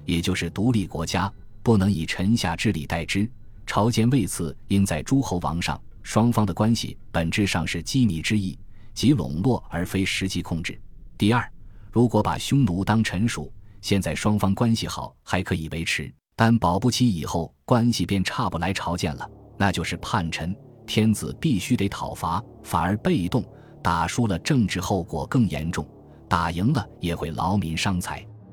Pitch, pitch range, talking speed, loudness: 100 Hz, 85-115 Hz, 250 characters per minute, -24 LUFS